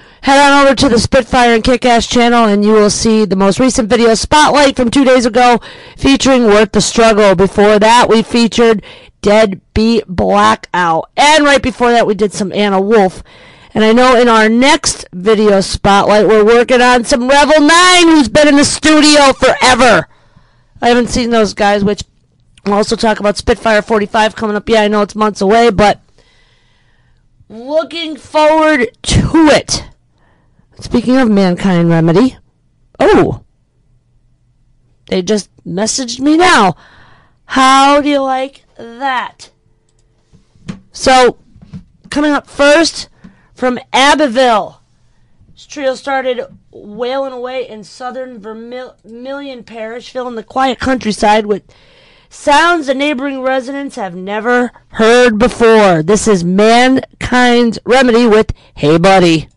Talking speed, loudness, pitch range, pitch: 140 wpm, -10 LUFS, 210-265 Hz, 235 Hz